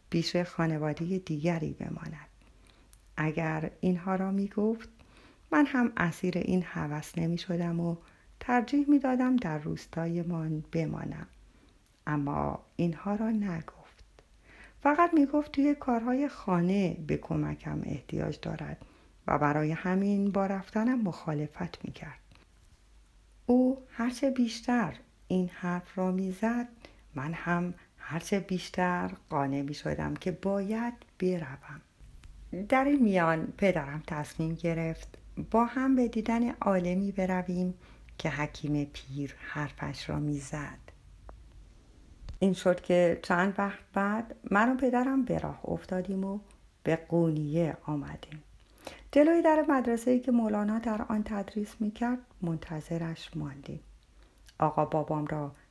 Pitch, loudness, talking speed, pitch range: 180 Hz, -31 LUFS, 125 wpm, 155-220 Hz